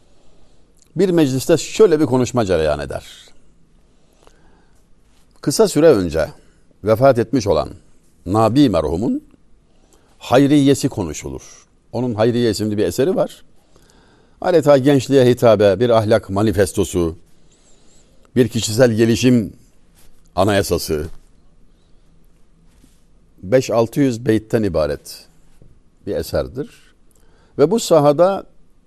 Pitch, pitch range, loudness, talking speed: 115 Hz, 90-140 Hz, -16 LUFS, 85 wpm